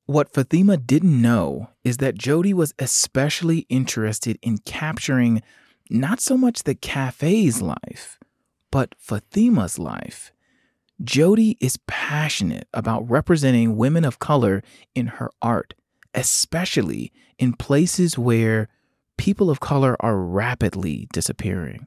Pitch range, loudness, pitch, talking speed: 115-165 Hz, -21 LUFS, 135 Hz, 115 wpm